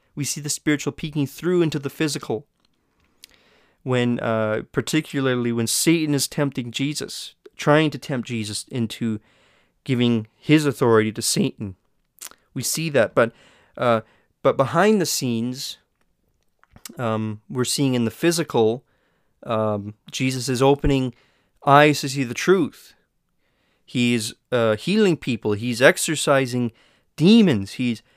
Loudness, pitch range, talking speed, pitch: -21 LUFS, 115-150 Hz, 130 wpm, 130 Hz